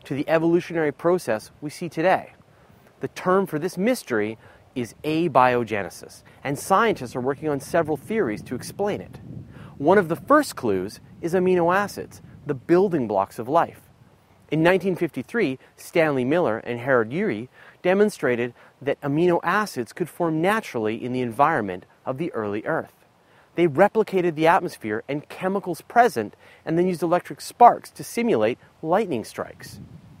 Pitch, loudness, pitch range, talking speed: 155 Hz, -23 LUFS, 125-180 Hz, 145 wpm